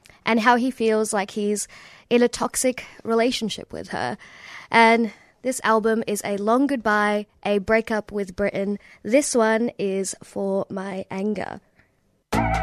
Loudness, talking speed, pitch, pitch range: -22 LUFS, 140 wpm, 220 Hz, 205-230 Hz